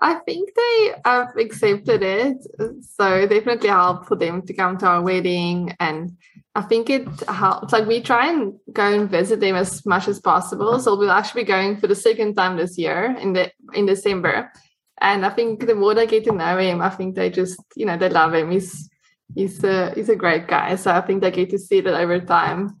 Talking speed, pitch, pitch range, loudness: 225 wpm, 195 Hz, 180-225 Hz, -19 LUFS